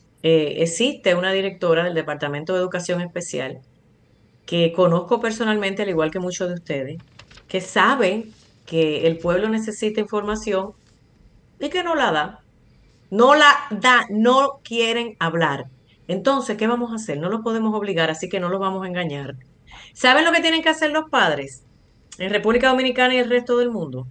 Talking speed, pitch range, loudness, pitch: 170 wpm, 165-235 Hz, -20 LUFS, 190 Hz